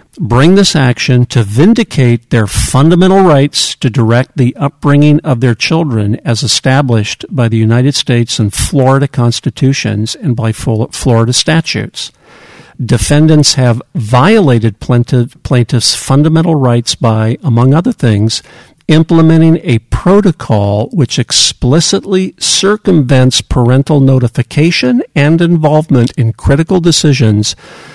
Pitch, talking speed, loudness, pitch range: 130 Hz, 110 wpm, -9 LUFS, 120-155 Hz